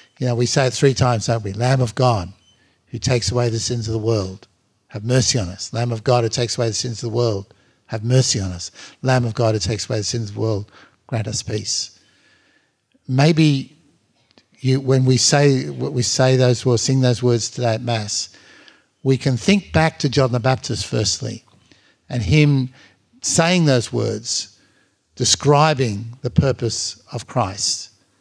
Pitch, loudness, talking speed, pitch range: 120 Hz, -19 LUFS, 185 wpm, 110-130 Hz